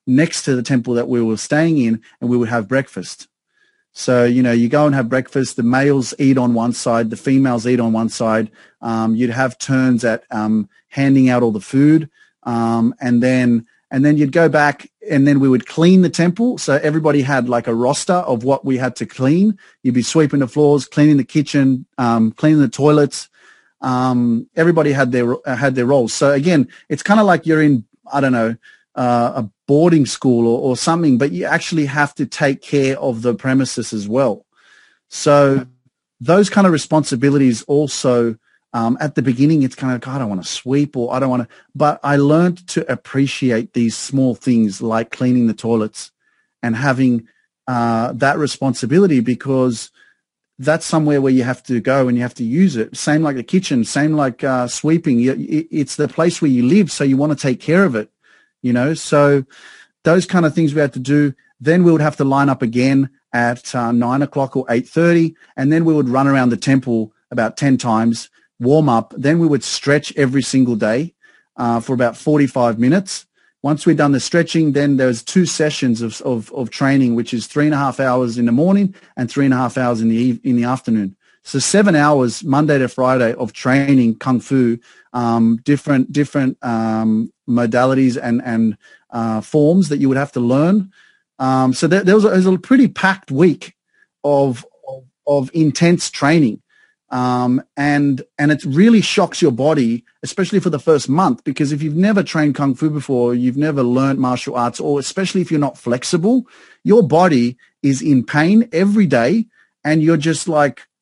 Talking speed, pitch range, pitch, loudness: 200 wpm, 120-150 Hz, 135 Hz, -16 LUFS